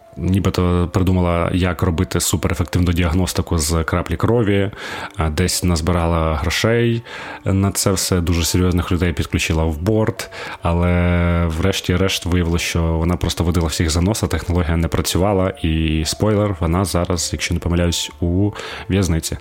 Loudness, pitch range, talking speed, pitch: -18 LUFS, 85-95 Hz, 135 wpm, 90 Hz